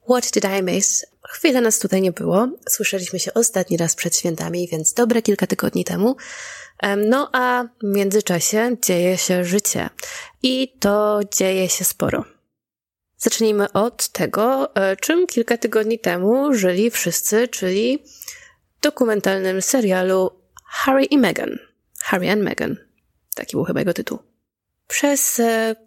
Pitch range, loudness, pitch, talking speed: 190-250 Hz, -19 LUFS, 215 Hz, 130 wpm